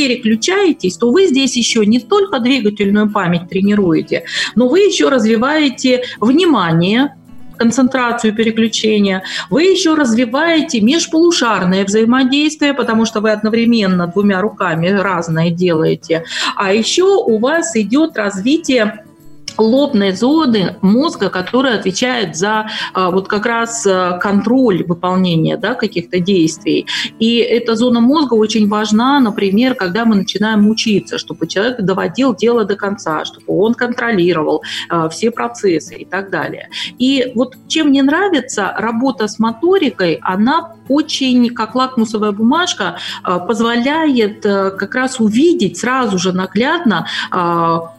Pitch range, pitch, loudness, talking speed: 195-255 Hz, 225 Hz, -14 LUFS, 125 wpm